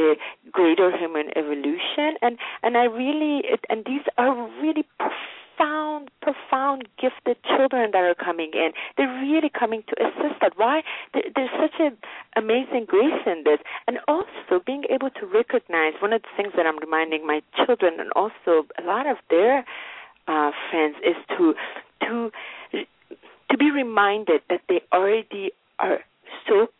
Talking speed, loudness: 150 wpm, -23 LUFS